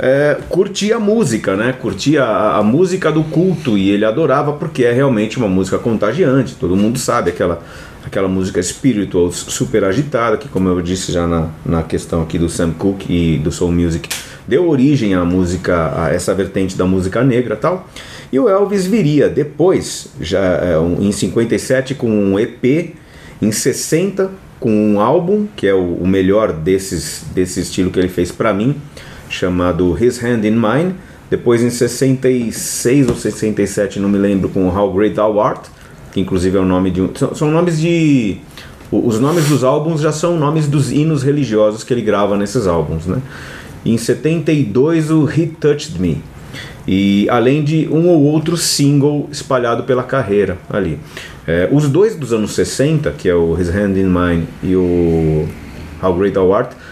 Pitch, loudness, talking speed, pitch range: 110 Hz, -15 LUFS, 180 wpm, 95-145 Hz